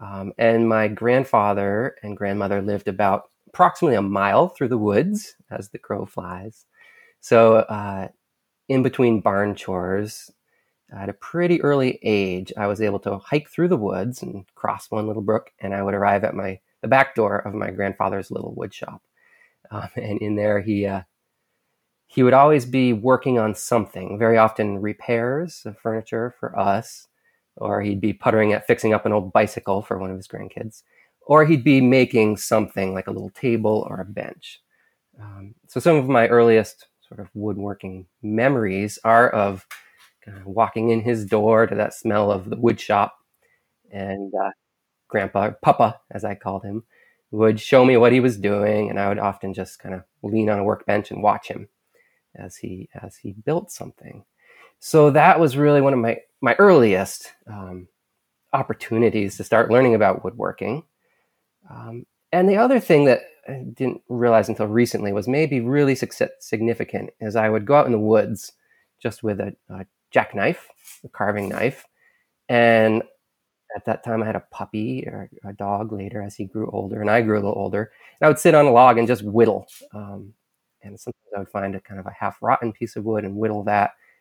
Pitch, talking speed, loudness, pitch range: 110 Hz, 185 wpm, -20 LUFS, 100-120 Hz